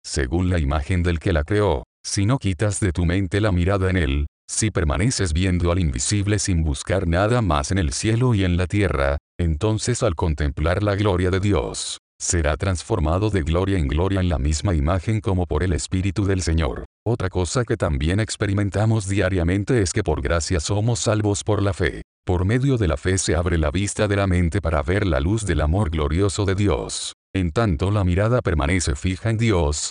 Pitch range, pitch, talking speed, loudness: 85-105 Hz, 95 Hz, 200 wpm, -21 LUFS